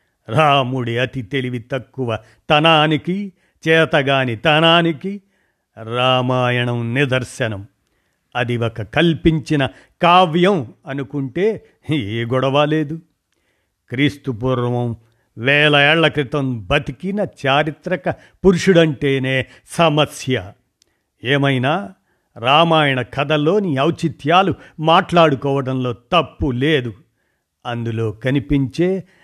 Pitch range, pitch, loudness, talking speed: 125-160 Hz, 140 Hz, -17 LUFS, 70 wpm